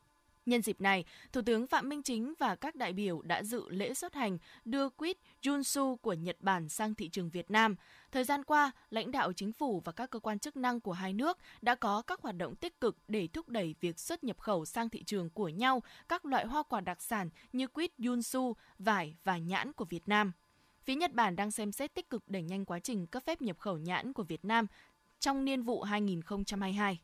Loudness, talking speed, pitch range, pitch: -36 LUFS, 225 wpm, 195-260 Hz, 225 Hz